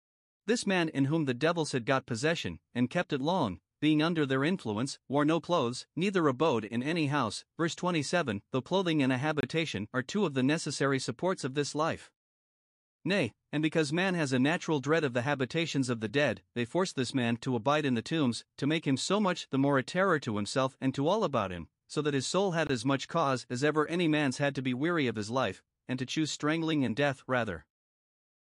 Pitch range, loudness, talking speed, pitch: 130-160 Hz, -30 LUFS, 225 wpm, 145 Hz